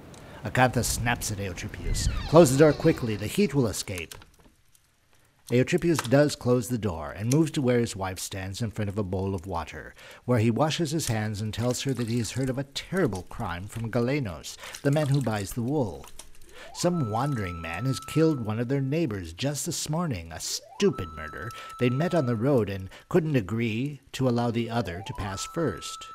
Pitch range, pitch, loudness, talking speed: 105-145 Hz, 120 Hz, -27 LUFS, 195 wpm